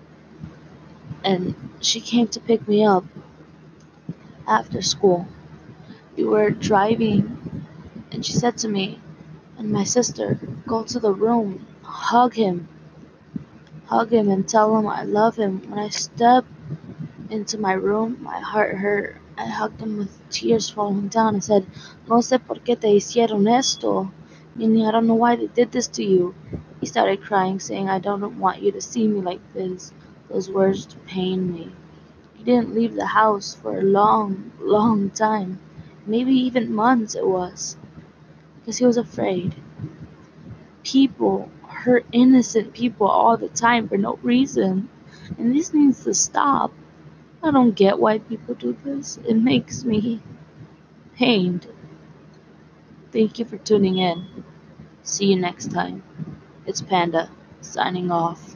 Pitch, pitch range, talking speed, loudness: 210 Hz, 190-230 Hz, 150 wpm, -21 LUFS